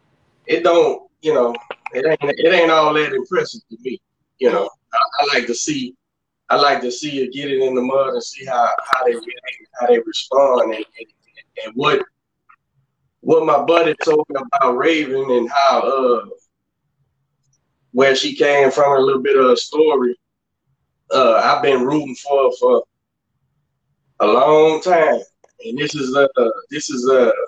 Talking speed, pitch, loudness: 170 wpm, 155 Hz, -16 LUFS